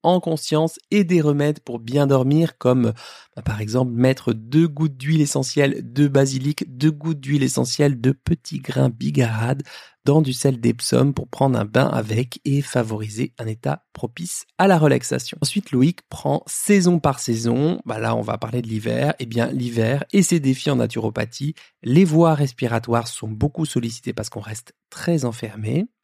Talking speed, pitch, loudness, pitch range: 175 wpm, 135 Hz, -21 LUFS, 120-150 Hz